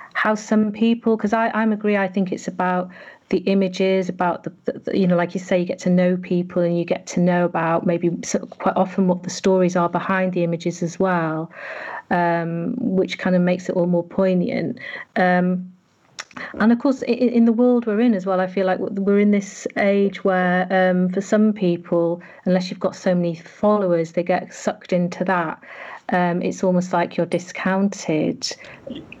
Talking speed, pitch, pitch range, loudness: 195 wpm, 185 Hz, 175-200 Hz, -20 LUFS